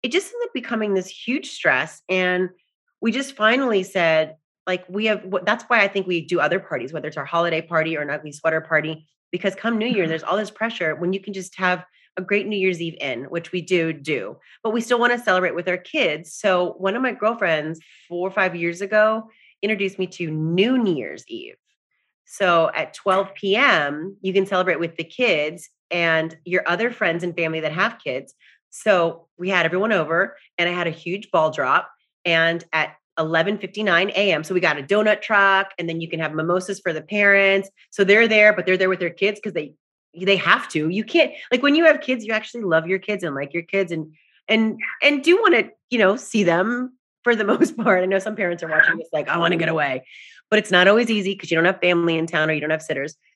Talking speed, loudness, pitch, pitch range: 235 wpm, -20 LUFS, 185 Hz, 165-215 Hz